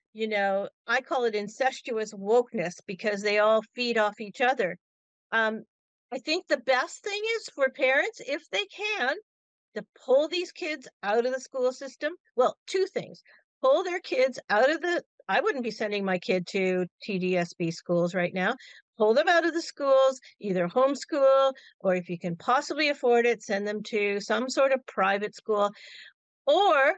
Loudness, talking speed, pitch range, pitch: -27 LUFS, 175 wpm, 205-290 Hz, 245 Hz